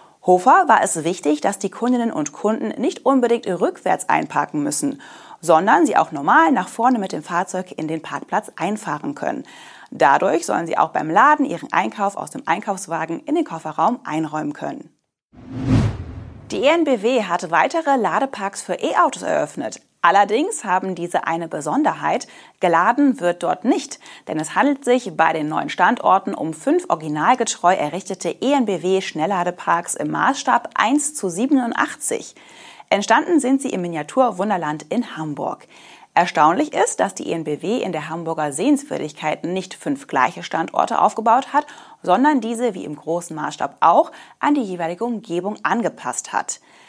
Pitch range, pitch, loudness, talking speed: 165-265 Hz, 200 Hz, -19 LUFS, 145 wpm